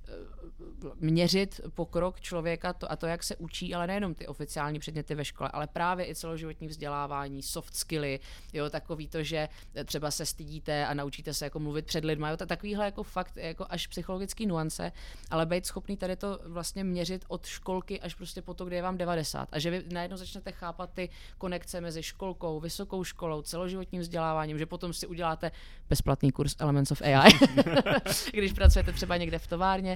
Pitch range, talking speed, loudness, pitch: 155-185 Hz, 180 wpm, -31 LUFS, 170 Hz